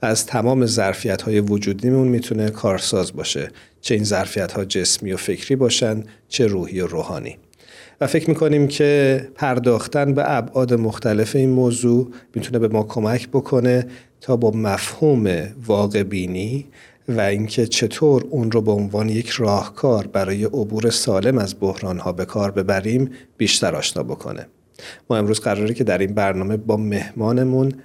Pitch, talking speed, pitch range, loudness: 115 Hz, 150 wpm, 105-130 Hz, -19 LUFS